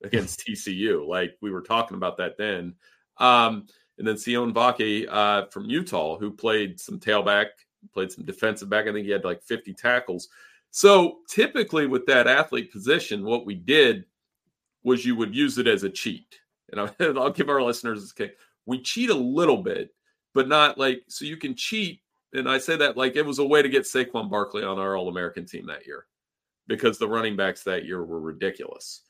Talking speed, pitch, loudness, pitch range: 200 wpm, 120 Hz, -24 LUFS, 105-150 Hz